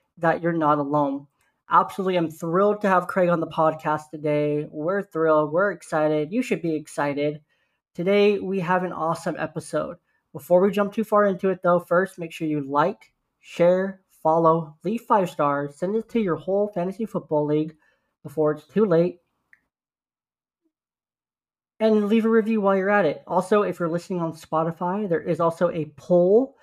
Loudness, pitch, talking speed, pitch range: -23 LUFS, 175 Hz, 175 wpm, 155-195 Hz